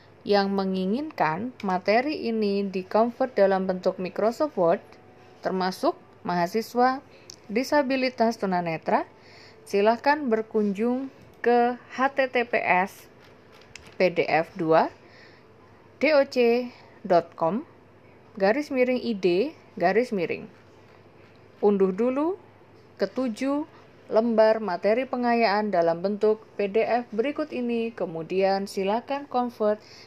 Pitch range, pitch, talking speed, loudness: 190-245 Hz, 220 Hz, 80 wpm, -25 LUFS